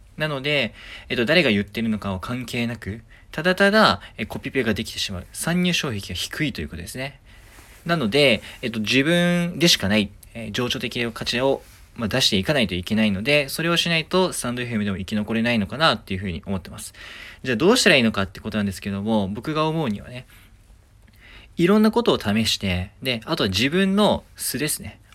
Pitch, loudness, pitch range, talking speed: 110 Hz, -21 LUFS, 100-140 Hz, 405 characters per minute